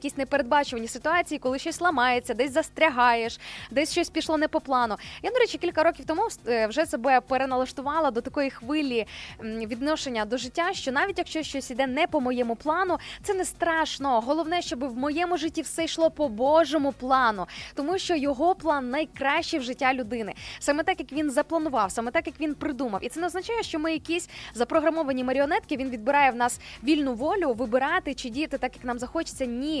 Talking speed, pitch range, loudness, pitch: 185 wpm, 255-325 Hz, -26 LUFS, 290 Hz